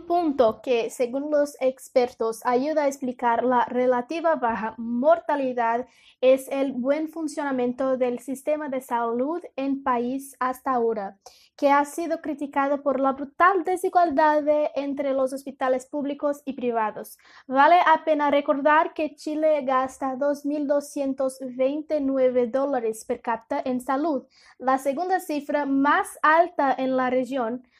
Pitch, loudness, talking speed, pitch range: 270 Hz, -24 LUFS, 130 wpm, 255-300 Hz